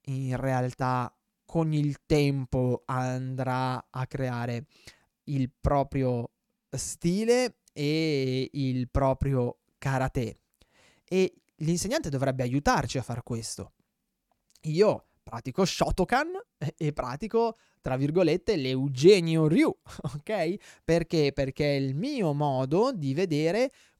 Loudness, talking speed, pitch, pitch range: -28 LUFS, 100 wpm, 140 Hz, 130-165 Hz